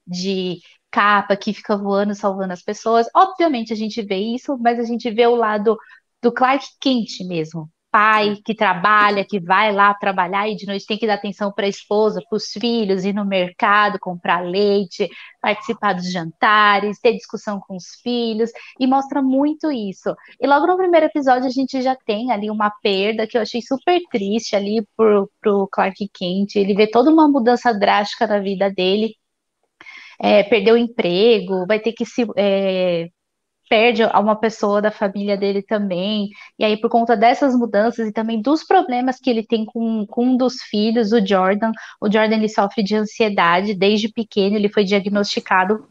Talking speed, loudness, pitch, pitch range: 180 wpm, -18 LUFS, 215 Hz, 200-235 Hz